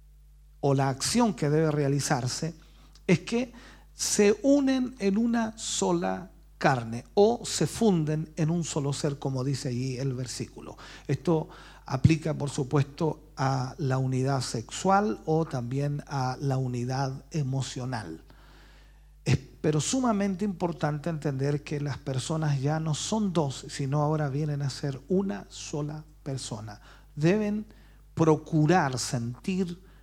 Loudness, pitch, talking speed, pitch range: -28 LUFS, 150 Hz, 125 wpm, 135-170 Hz